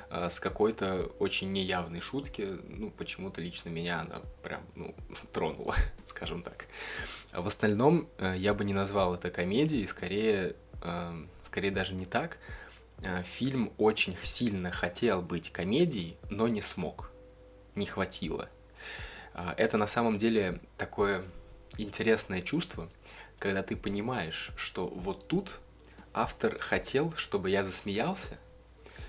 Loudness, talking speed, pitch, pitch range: -32 LUFS, 120 wpm, 100 Hz, 90-110 Hz